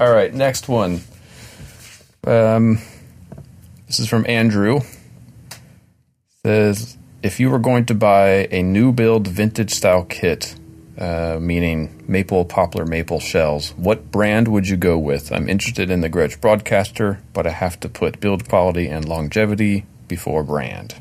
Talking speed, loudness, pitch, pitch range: 150 wpm, -18 LUFS, 100 Hz, 85-115 Hz